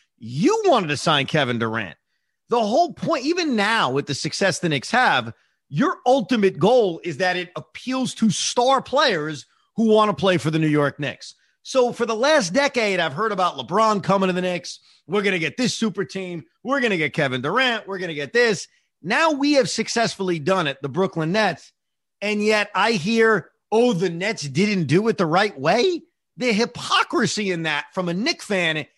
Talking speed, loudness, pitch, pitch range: 200 wpm, -21 LUFS, 195 Hz, 160-235 Hz